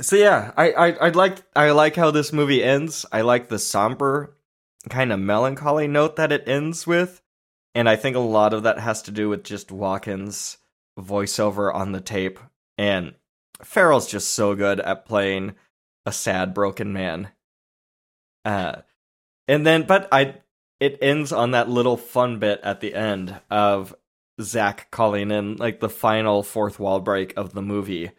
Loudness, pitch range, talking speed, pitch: -21 LUFS, 100-135 Hz, 170 wpm, 110 Hz